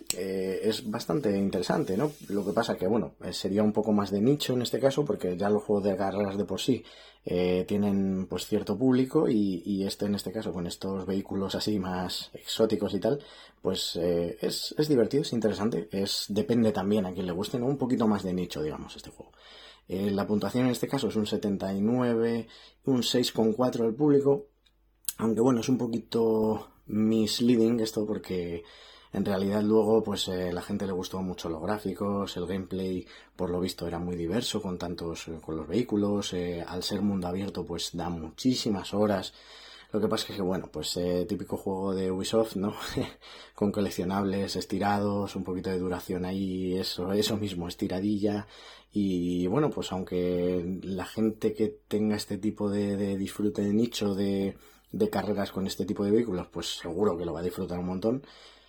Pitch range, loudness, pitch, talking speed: 90-110 Hz, -29 LUFS, 100 Hz, 185 wpm